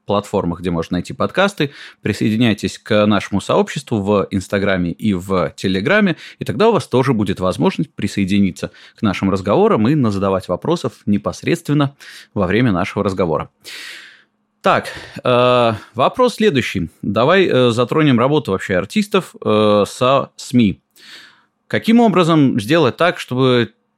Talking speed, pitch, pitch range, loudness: 125 wpm, 110 Hz, 100-150 Hz, -16 LUFS